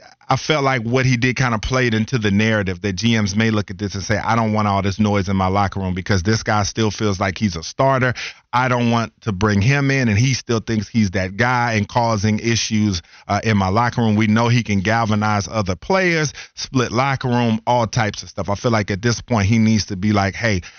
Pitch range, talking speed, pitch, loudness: 100-120 Hz, 250 wpm, 110 Hz, -18 LUFS